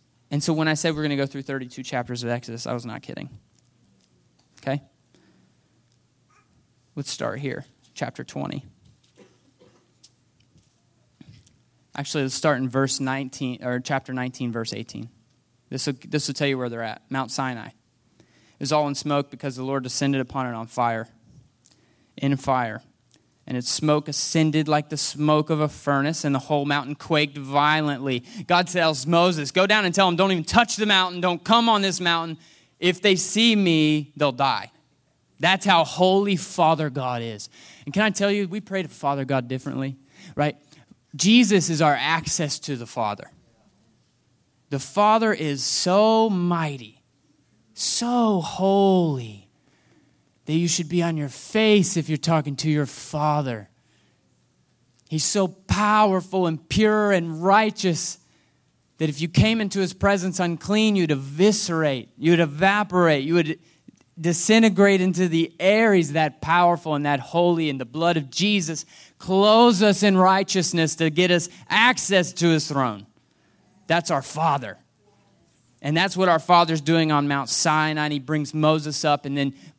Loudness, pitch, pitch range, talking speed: -22 LUFS, 155 Hz, 135-180 Hz, 155 wpm